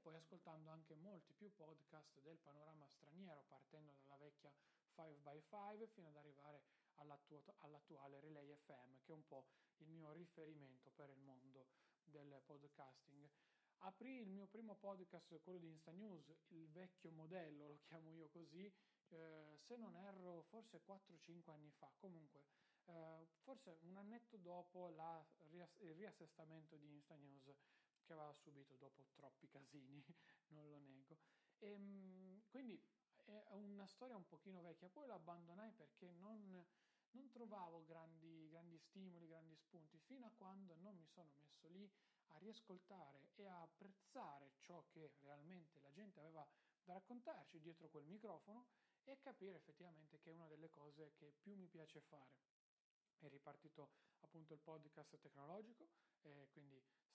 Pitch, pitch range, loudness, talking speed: 165 Hz, 150-190 Hz, -64 LUFS, 150 wpm